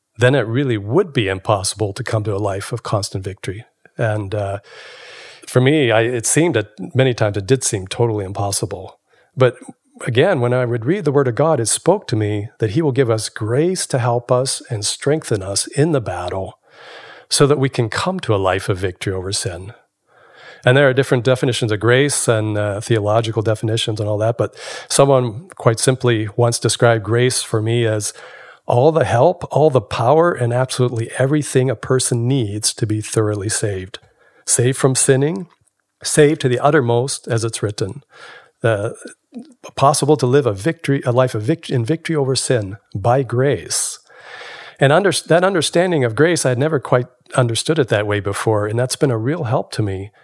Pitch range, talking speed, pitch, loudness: 110-140 Hz, 190 wpm, 120 Hz, -17 LUFS